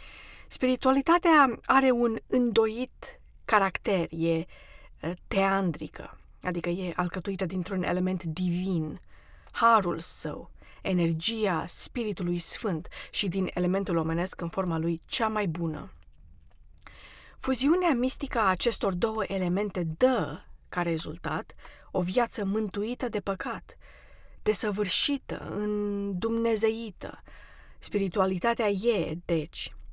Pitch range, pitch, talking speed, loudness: 175-225 Hz, 195 Hz, 95 wpm, -27 LUFS